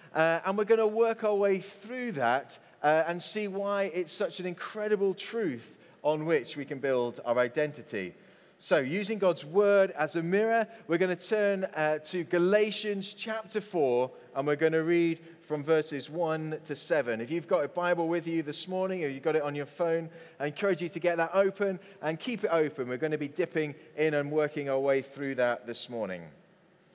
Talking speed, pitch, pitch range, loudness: 205 wpm, 170 Hz, 150-195 Hz, -30 LUFS